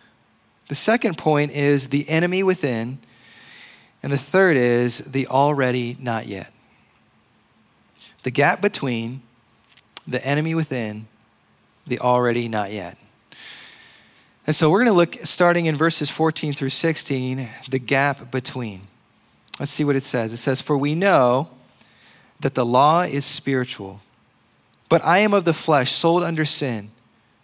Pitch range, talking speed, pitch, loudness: 120-155 Hz, 140 wpm, 135 Hz, -20 LUFS